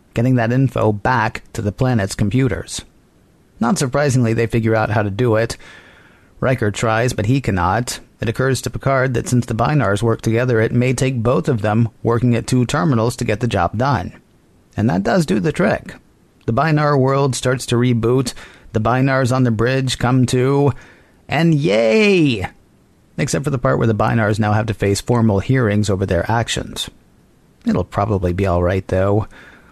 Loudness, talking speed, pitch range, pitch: -17 LUFS, 180 wpm, 110-130 Hz, 120 Hz